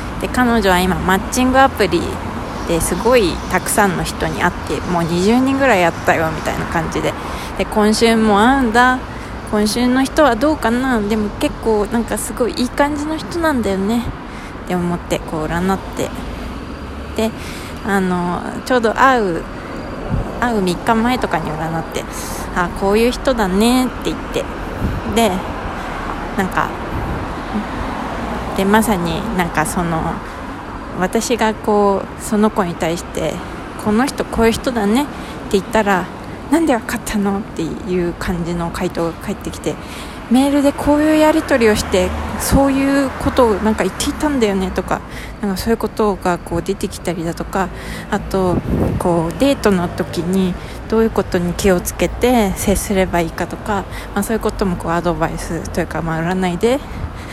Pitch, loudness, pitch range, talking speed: 215 Hz, -17 LUFS, 185-245 Hz, 310 characters per minute